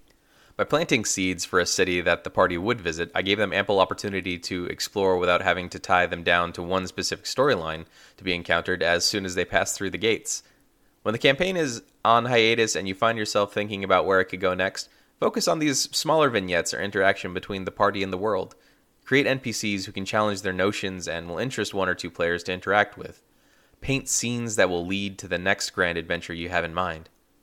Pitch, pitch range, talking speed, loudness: 95 Hz, 90-105 Hz, 220 wpm, -24 LUFS